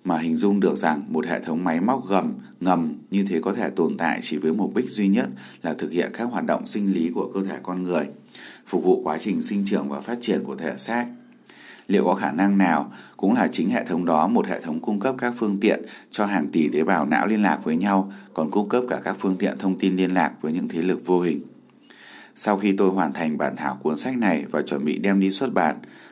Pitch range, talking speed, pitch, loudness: 95-115 Hz, 255 wpm, 100 Hz, -23 LUFS